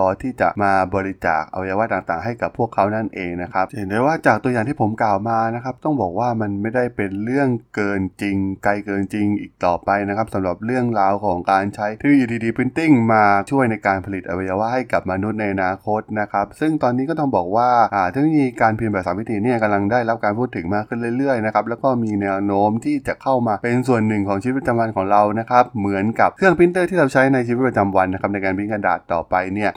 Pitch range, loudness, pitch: 100-125 Hz, -19 LUFS, 105 Hz